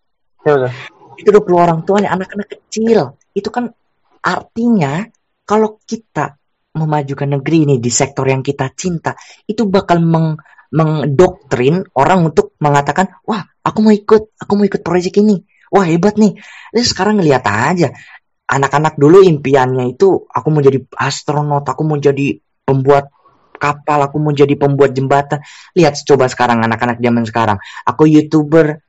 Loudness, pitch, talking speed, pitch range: -13 LUFS, 155 Hz, 145 wpm, 140-195 Hz